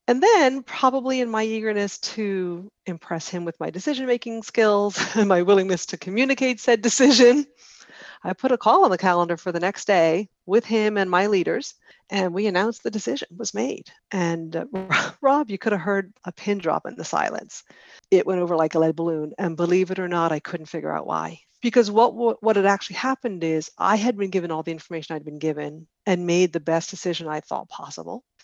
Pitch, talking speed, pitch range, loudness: 190 Hz, 210 wpm, 170-225 Hz, -22 LUFS